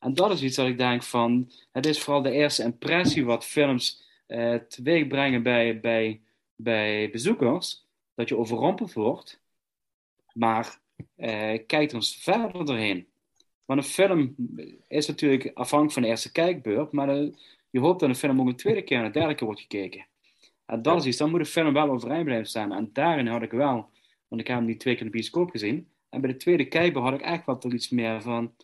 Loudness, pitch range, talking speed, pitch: -26 LUFS, 115-150 Hz, 210 wpm, 130 Hz